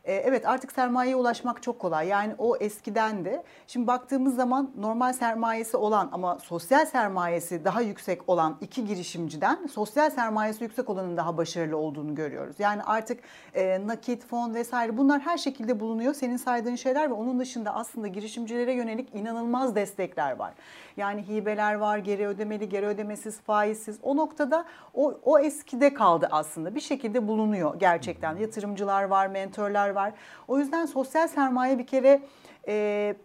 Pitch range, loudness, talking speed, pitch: 205-255 Hz, -27 LUFS, 150 wpm, 225 Hz